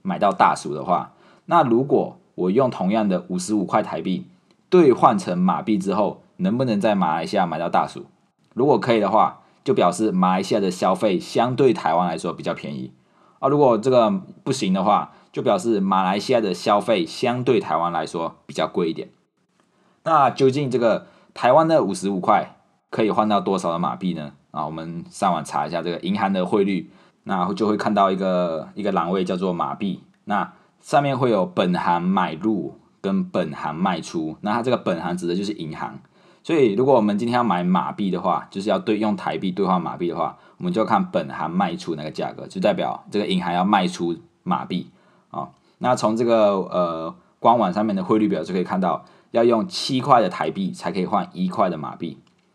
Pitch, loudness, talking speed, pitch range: 95 Hz, -21 LUFS, 295 characters per minute, 85-110 Hz